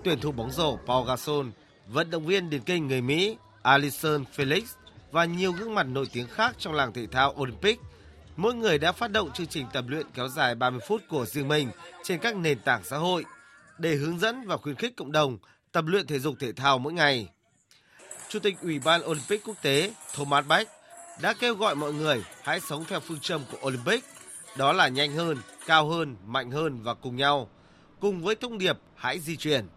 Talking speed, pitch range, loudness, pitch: 210 wpm, 135-180 Hz, -27 LUFS, 150 Hz